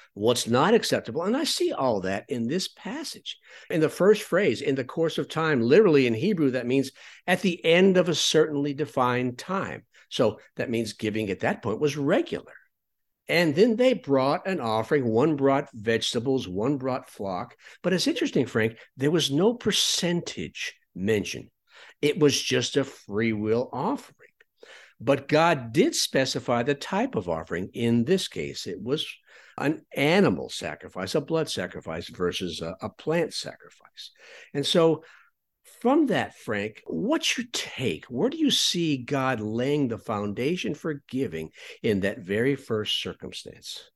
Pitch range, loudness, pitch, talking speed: 120-170 Hz, -25 LUFS, 140 Hz, 160 wpm